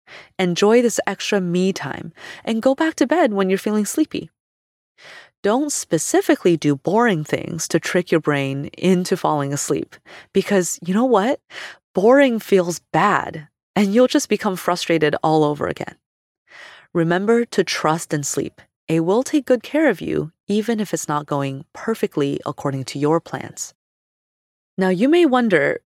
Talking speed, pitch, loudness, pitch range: 155 wpm, 190 Hz, -19 LUFS, 160-230 Hz